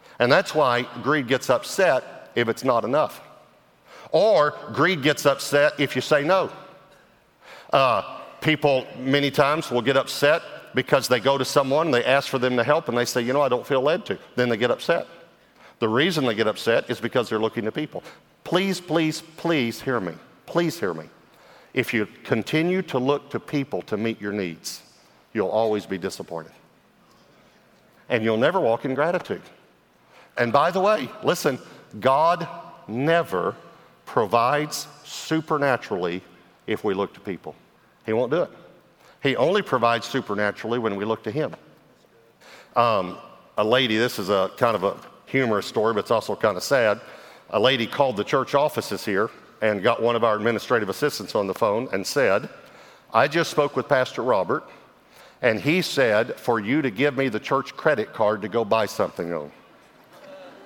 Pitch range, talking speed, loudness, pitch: 115-150 Hz, 175 wpm, -23 LUFS, 130 Hz